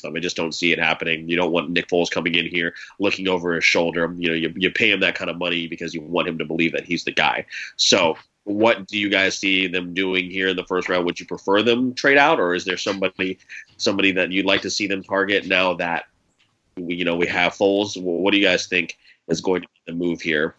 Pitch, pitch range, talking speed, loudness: 90 Hz, 85-95 Hz, 260 wpm, -20 LUFS